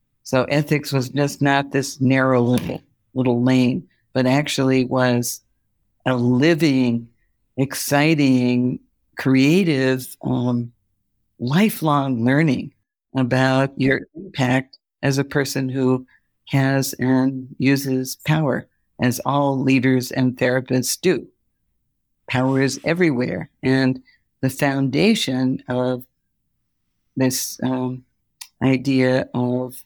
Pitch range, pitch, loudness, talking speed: 125-135 Hz, 130 Hz, -20 LUFS, 95 wpm